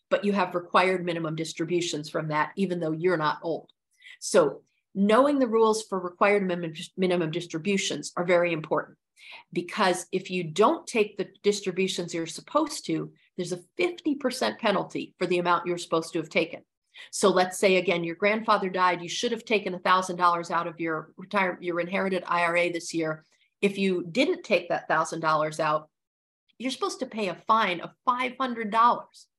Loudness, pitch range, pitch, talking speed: -26 LUFS, 170-215 Hz, 185 Hz, 165 wpm